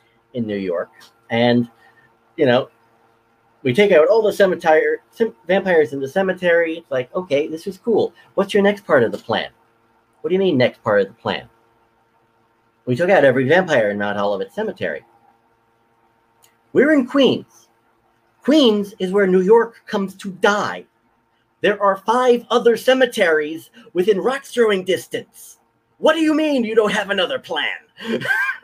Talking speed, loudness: 160 wpm, -18 LUFS